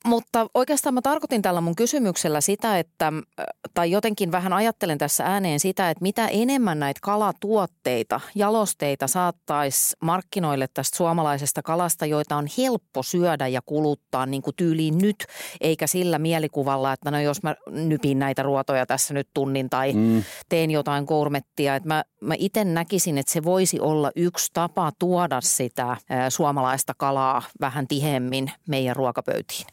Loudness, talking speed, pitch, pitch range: -23 LUFS, 145 wpm, 155 Hz, 140-185 Hz